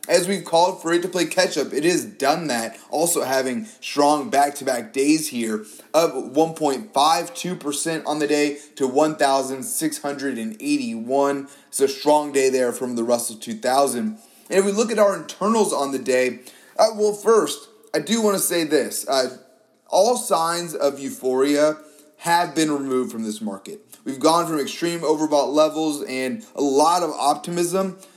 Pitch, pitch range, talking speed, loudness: 150 Hz, 135-180 Hz, 160 wpm, -21 LUFS